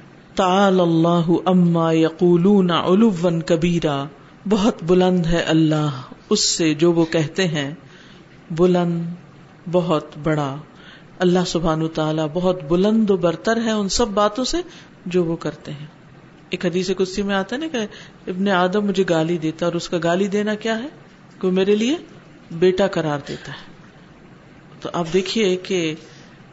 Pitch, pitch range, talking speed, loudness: 175 Hz, 160-195 Hz, 150 wpm, -19 LUFS